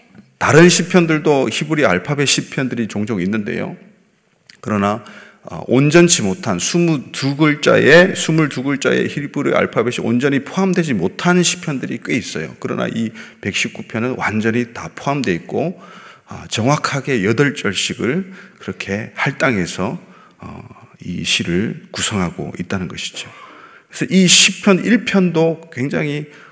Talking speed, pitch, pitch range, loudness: 260 characters per minute, 160 Hz, 140-185 Hz, -16 LUFS